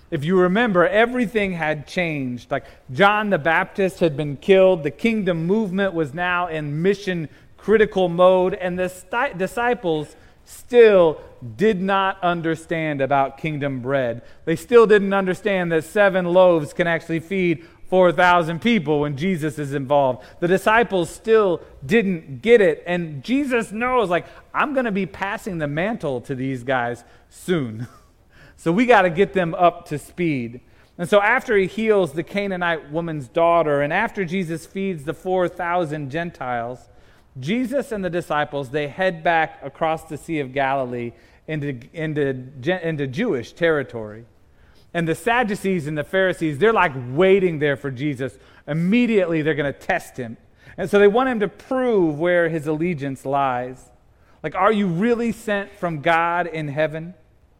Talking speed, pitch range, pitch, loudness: 155 wpm, 145-195 Hz, 170 Hz, -20 LUFS